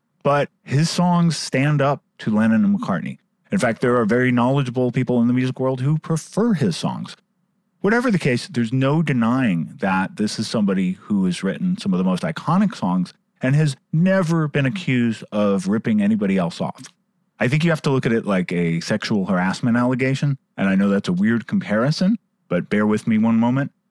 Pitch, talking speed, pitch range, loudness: 155 Hz, 200 wpm, 125-195 Hz, -20 LUFS